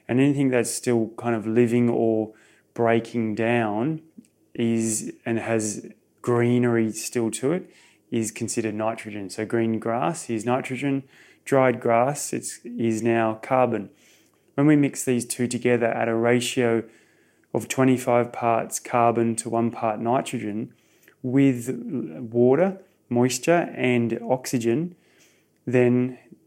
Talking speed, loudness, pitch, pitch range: 120 wpm, -24 LUFS, 120 Hz, 115-125 Hz